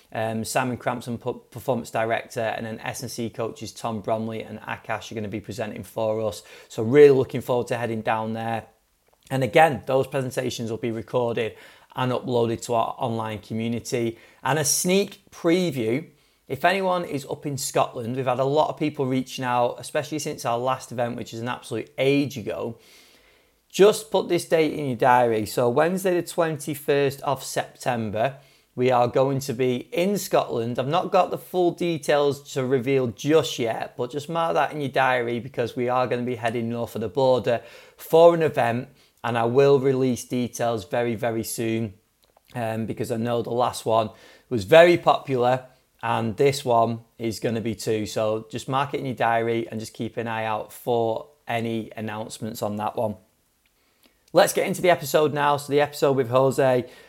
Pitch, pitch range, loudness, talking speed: 125 Hz, 115-140 Hz, -24 LUFS, 185 wpm